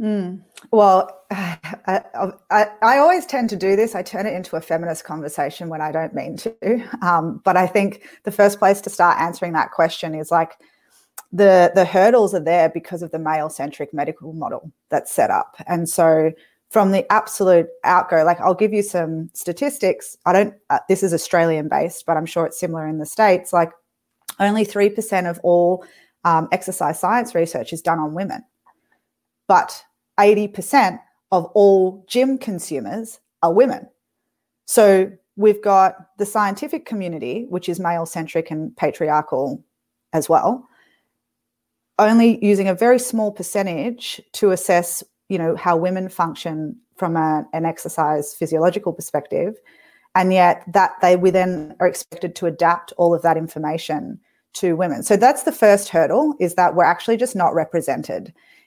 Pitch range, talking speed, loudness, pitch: 165-210 Hz, 160 wpm, -18 LUFS, 185 Hz